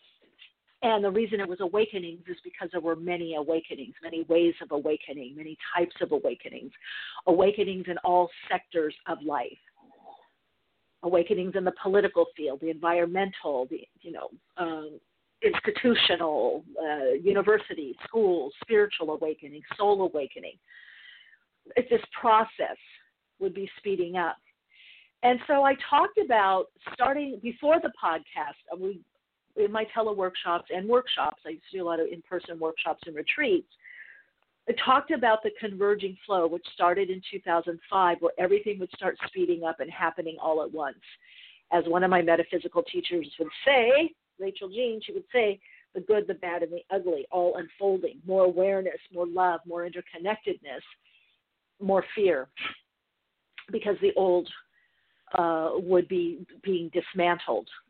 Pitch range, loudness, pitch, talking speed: 170-230 Hz, -27 LUFS, 190 Hz, 145 wpm